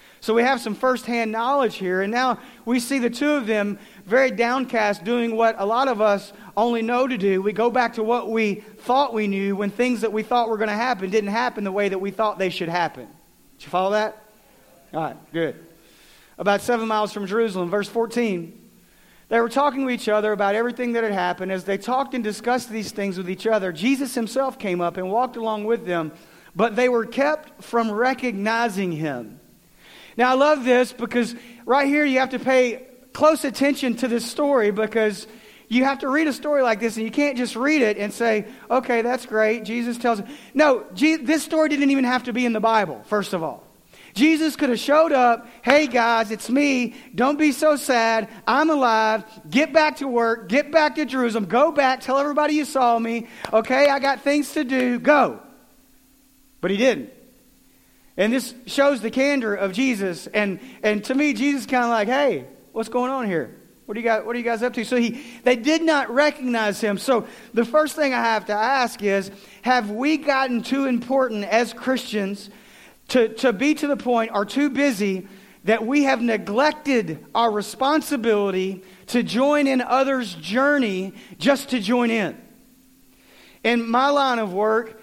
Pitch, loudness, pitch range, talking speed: 235 Hz, -21 LUFS, 215-265 Hz, 200 wpm